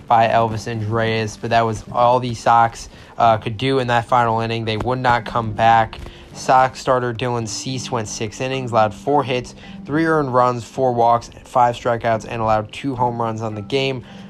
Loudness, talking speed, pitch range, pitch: -19 LUFS, 195 wpm, 115-130 Hz, 120 Hz